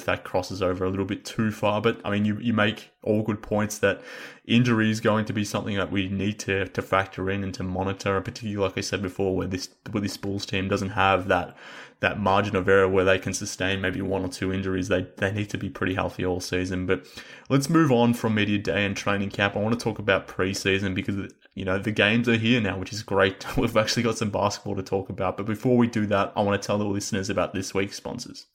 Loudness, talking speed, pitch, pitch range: -25 LUFS, 250 wpm, 100 Hz, 95-105 Hz